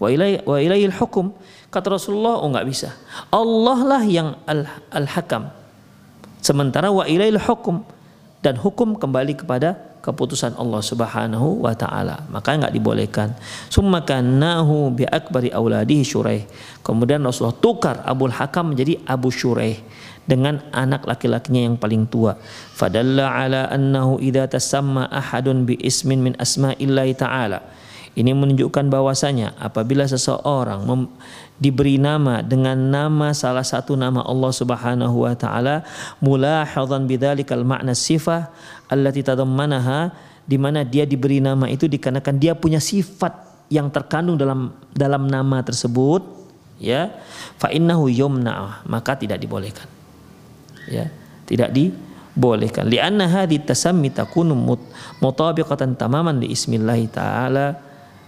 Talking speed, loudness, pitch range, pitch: 120 wpm, -19 LUFS, 125-155 Hz, 135 Hz